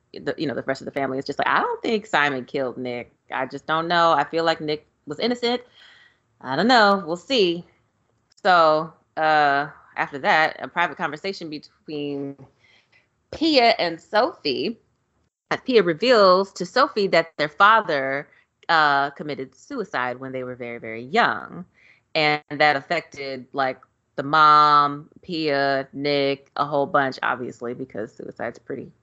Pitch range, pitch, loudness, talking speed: 135-170 Hz, 150 Hz, -21 LUFS, 155 wpm